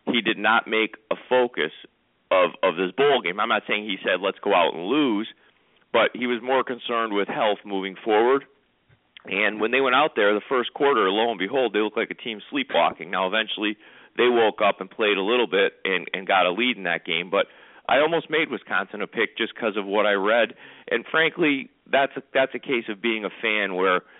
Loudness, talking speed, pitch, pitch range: -23 LUFS, 225 wpm, 115 Hz, 105-130 Hz